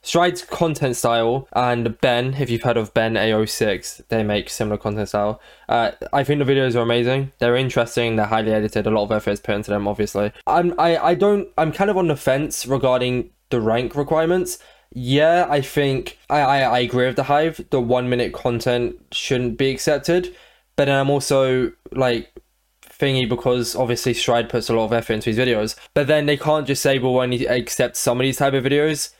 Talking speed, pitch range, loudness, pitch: 210 wpm, 115-145 Hz, -20 LUFS, 125 Hz